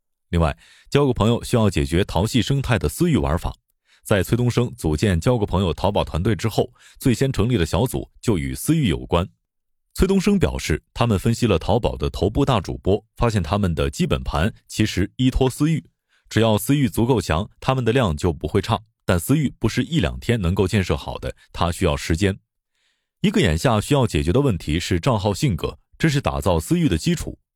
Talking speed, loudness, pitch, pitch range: 305 characters per minute, -21 LUFS, 105 Hz, 85-125 Hz